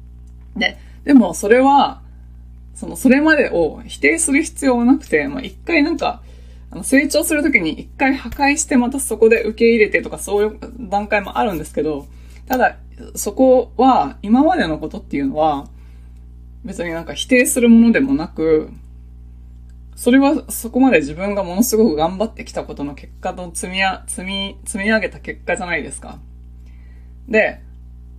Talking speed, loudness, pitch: 315 characters per minute, -16 LUFS, 200 Hz